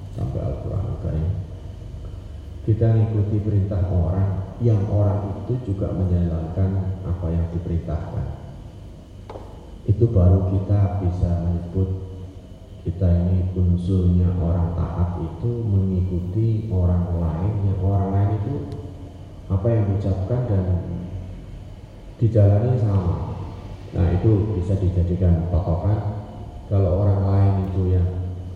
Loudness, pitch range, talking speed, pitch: -22 LUFS, 90-100 Hz, 105 wpm, 95 Hz